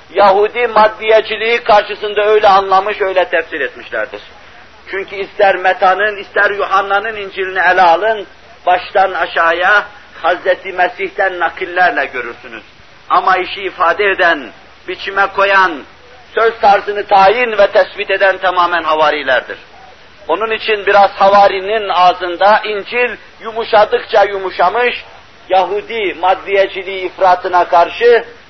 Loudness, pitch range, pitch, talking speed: -12 LUFS, 185-215 Hz, 195 Hz, 100 wpm